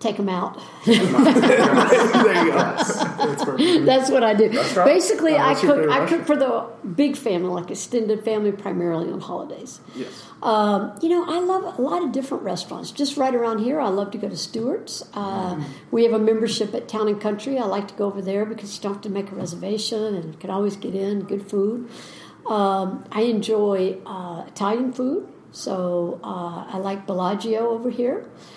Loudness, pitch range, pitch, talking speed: -21 LUFS, 195-245 Hz, 215 Hz, 185 wpm